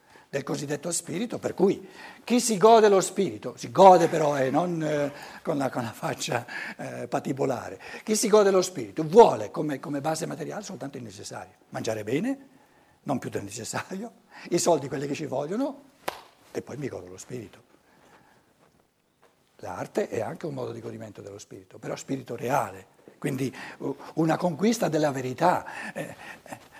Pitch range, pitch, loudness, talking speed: 145-215 Hz, 165 Hz, -26 LUFS, 165 wpm